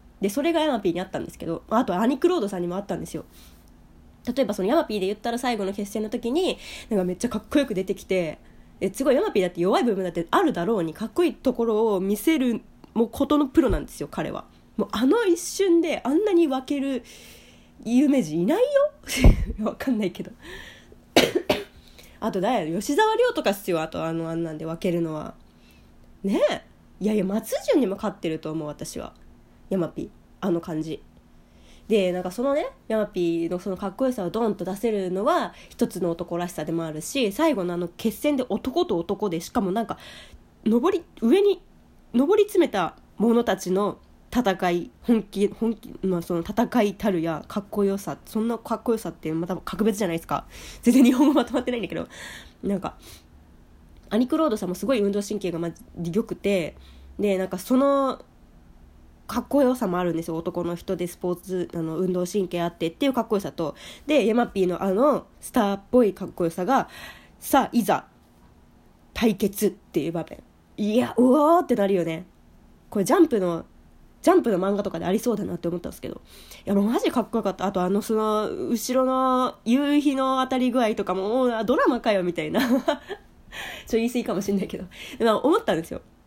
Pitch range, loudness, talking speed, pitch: 180-255 Hz, -24 LUFS, 370 characters per minute, 210 Hz